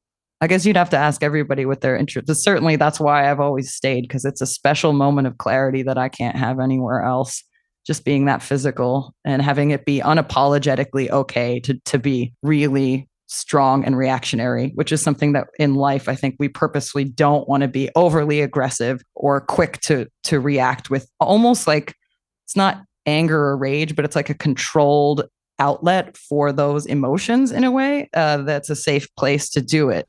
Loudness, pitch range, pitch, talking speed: -19 LUFS, 135-150 Hz, 145 Hz, 190 wpm